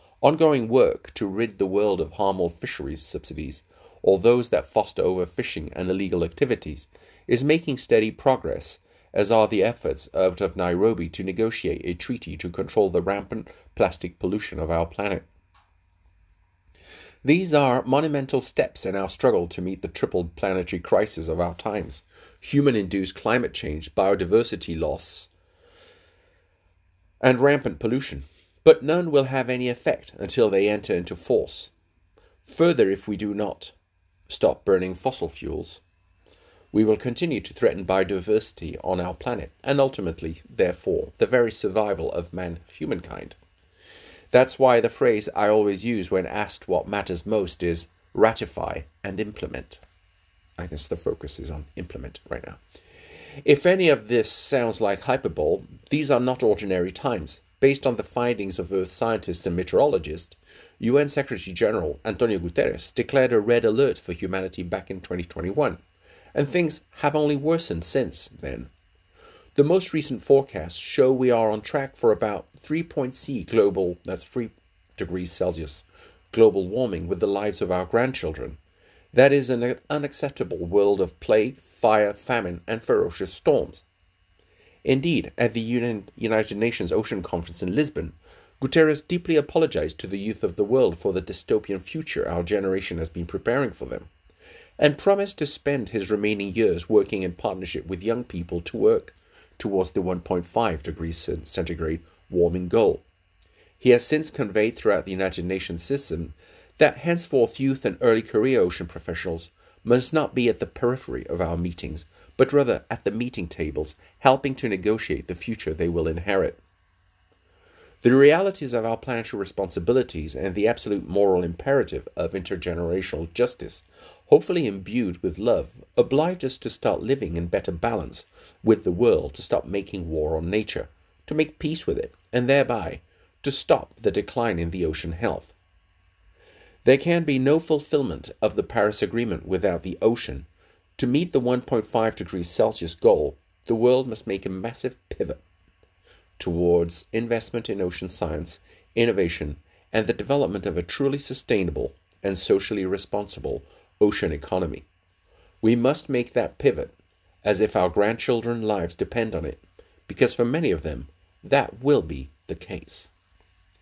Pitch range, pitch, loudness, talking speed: 90-125 Hz, 100 Hz, -24 LUFS, 150 wpm